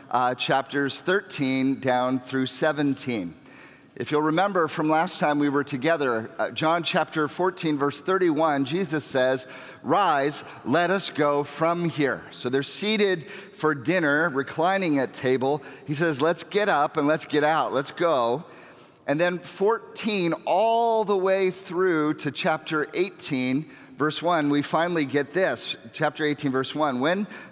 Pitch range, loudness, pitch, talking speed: 140-180 Hz, -24 LUFS, 155 Hz, 150 wpm